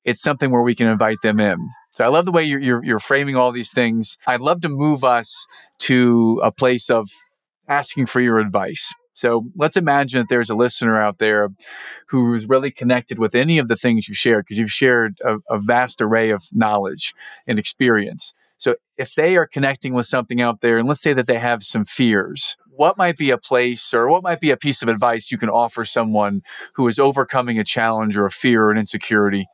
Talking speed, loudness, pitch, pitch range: 220 wpm, -18 LUFS, 120 Hz, 110-135 Hz